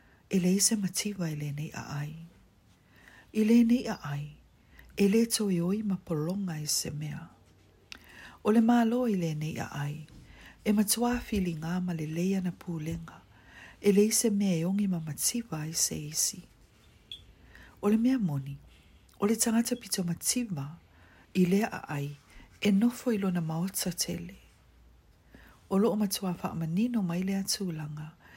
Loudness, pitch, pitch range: -29 LUFS, 175 Hz, 150-210 Hz